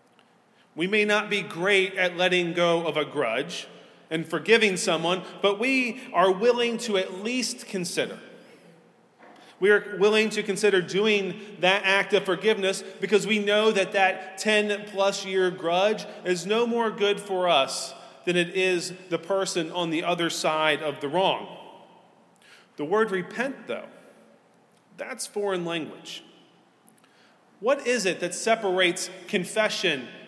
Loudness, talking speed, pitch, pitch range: -24 LUFS, 145 wpm, 195 Hz, 180-215 Hz